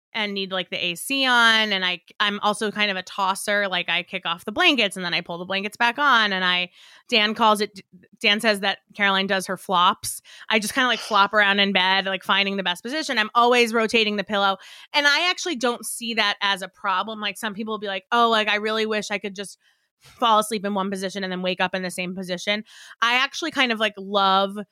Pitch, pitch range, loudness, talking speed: 205 Hz, 190-225 Hz, -21 LUFS, 245 wpm